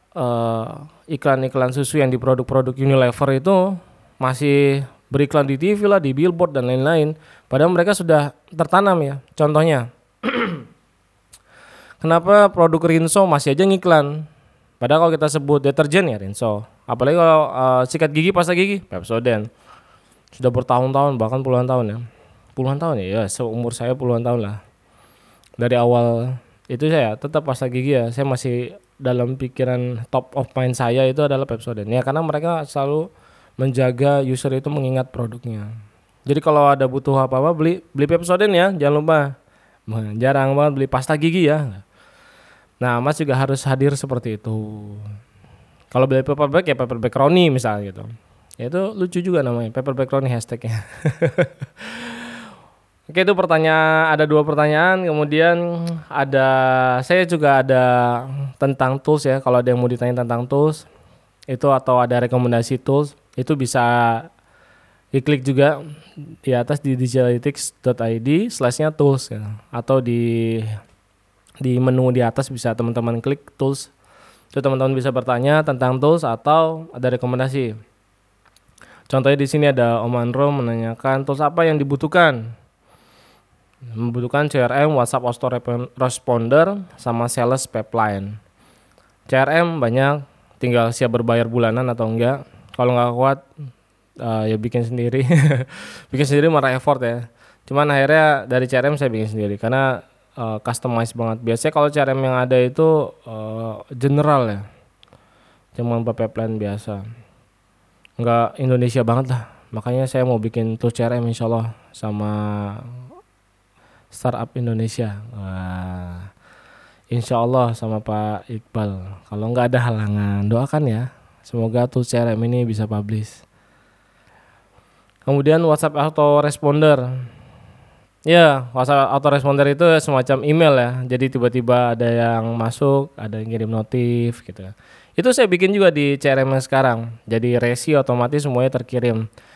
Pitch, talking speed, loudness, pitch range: 130 Hz, 135 wpm, -18 LUFS, 115-145 Hz